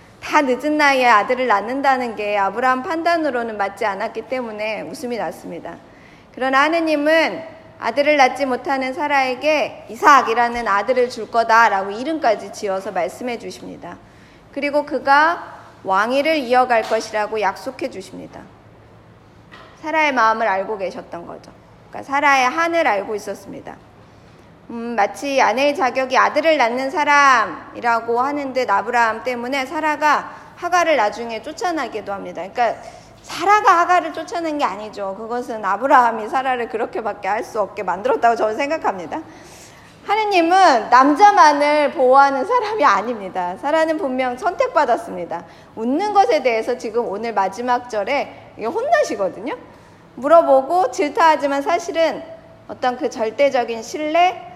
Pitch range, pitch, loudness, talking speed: 225-305 Hz, 260 Hz, -18 LUFS, 335 characters per minute